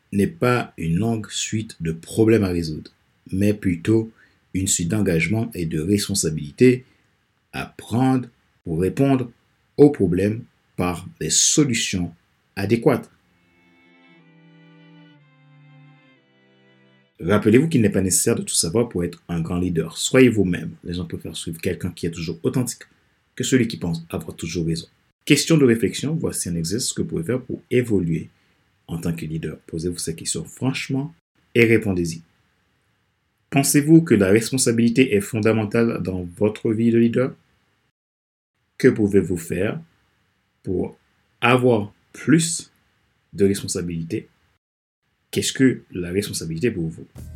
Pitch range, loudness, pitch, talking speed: 85-125 Hz, -21 LUFS, 105 Hz, 135 wpm